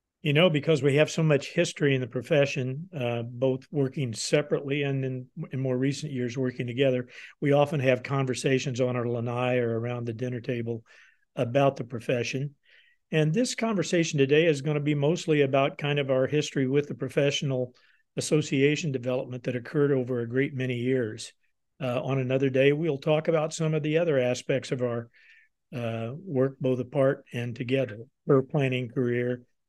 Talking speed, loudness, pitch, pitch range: 175 wpm, -27 LUFS, 135 Hz, 125-150 Hz